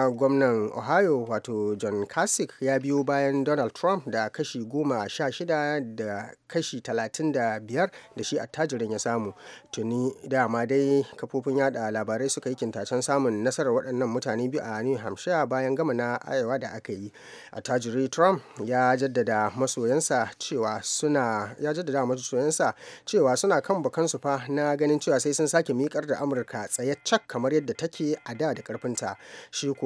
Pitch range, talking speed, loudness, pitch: 115-145 Hz, 120 wpm, -27 LUFS, 135 Hz